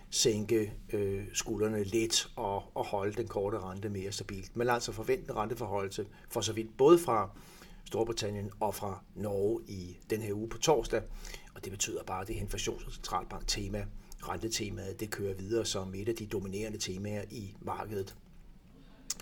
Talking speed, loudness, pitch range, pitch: 160 wpm, -34 LUFS, 100-110 Hz, 105 Hz